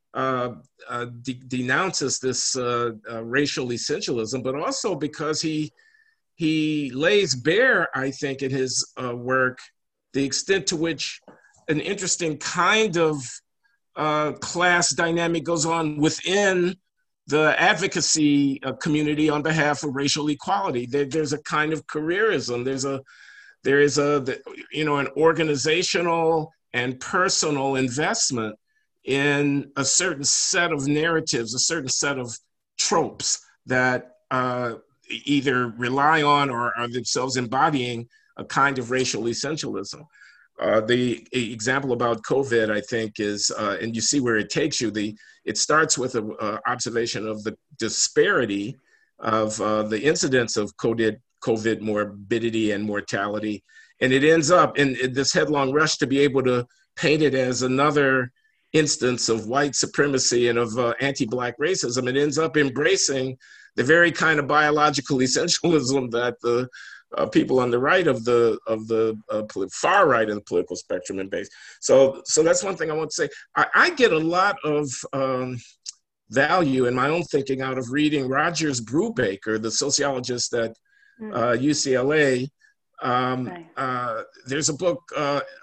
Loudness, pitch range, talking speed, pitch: -22 LUFS, 125-155 Hz, 150 wpm, 140 Hz